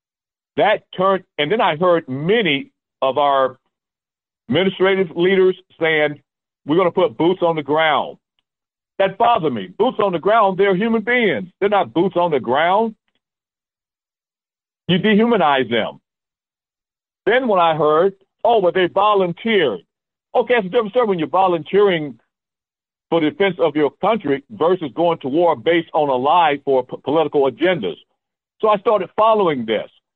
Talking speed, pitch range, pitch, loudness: 155 wpm, 160-205 Hz, 185 Hz, -17 LUFS